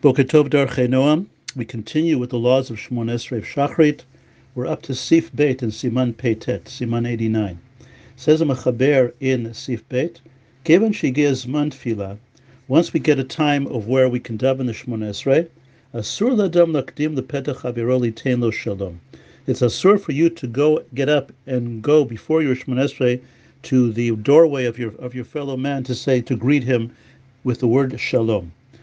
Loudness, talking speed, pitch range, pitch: -20 LUFS, 160 wpm, 120-145 Hz, 130 Hz